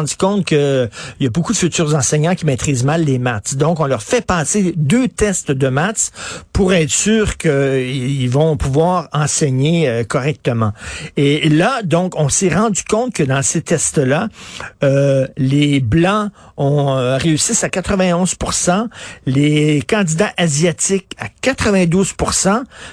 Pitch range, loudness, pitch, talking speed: 140-185 Hz, -15 LUFS, 160 Hz, 145 wpm